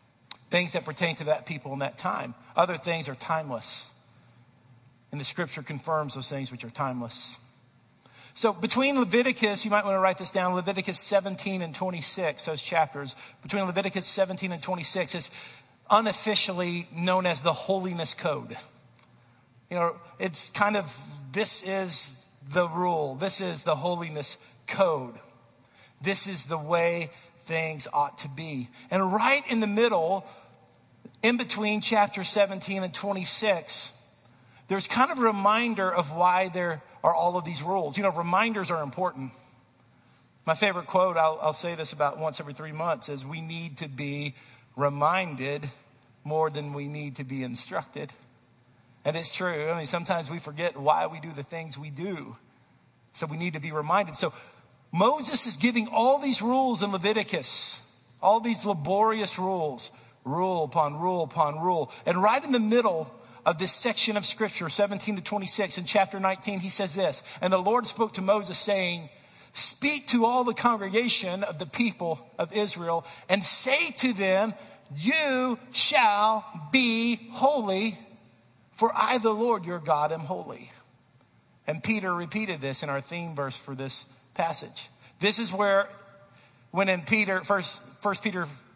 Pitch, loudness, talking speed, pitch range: 175 Hz, -26 LUFS, 160 wpm, 145-200 Hz